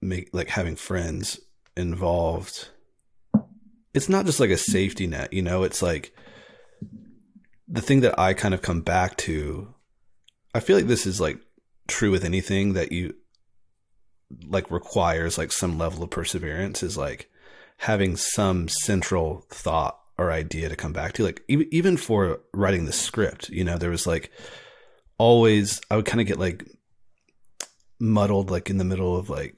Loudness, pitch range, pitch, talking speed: -24 LUFS, 85-105 Hz, 95 Hz, 165 wpm